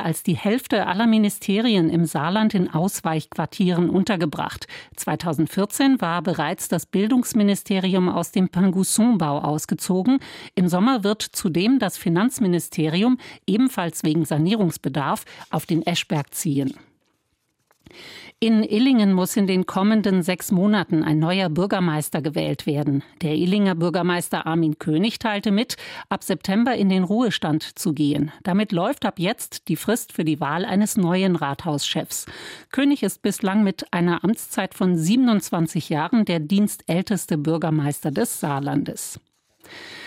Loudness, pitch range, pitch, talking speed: -22 LUFS, 165-210 Hz, 185 Hz, 125 wpm